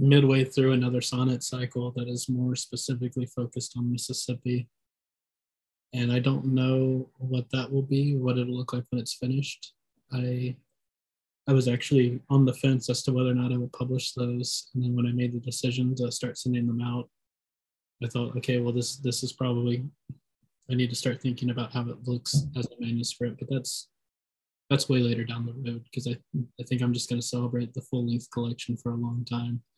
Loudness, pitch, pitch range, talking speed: -28 LUFS, 125 Hz, 120-130 Hz, 195 wpm